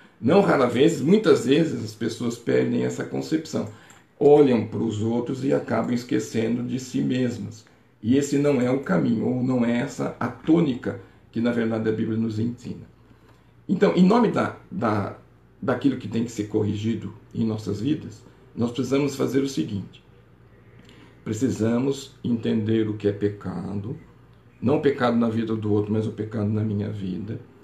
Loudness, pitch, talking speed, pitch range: -24 LUFS, 115 Hz, 165 wpm, 105-125 Hz